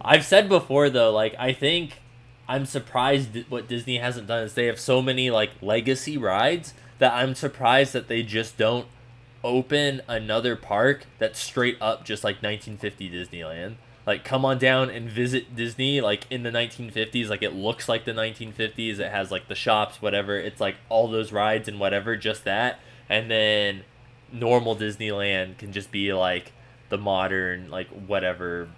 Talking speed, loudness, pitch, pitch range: 170 wpm, -24 LUFS, 115 Hz, 105-125 Hz